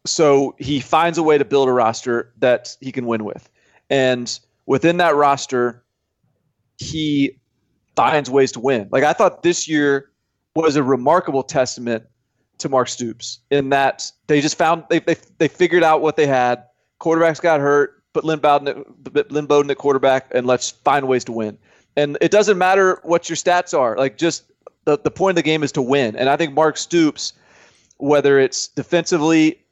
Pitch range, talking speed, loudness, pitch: 130-160 Hz, 180 wpm, -18 LUFS, 140 Hz